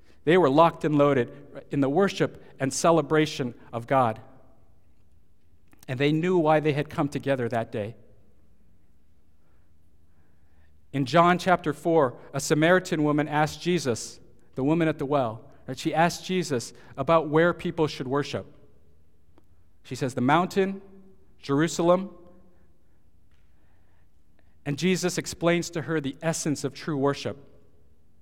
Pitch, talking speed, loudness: 135 Hz, 130 wpm, -25 LUFS